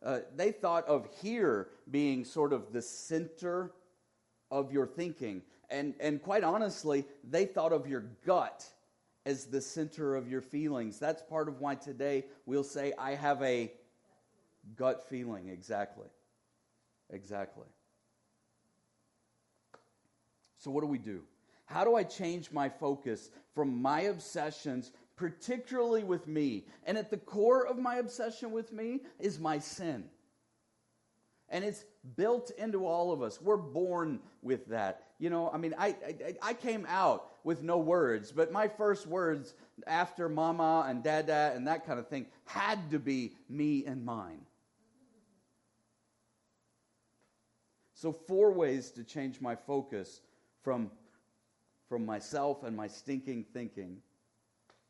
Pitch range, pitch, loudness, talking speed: 120-170 Hz, 140 Hz, -35 LUFS, 140 wpm